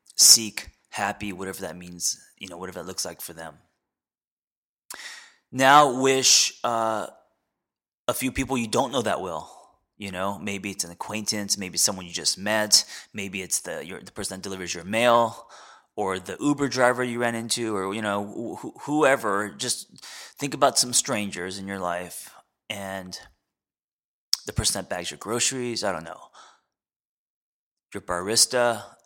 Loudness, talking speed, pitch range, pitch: -23 LUFS, 160 wpm, 95-120 Hz, 105 Hz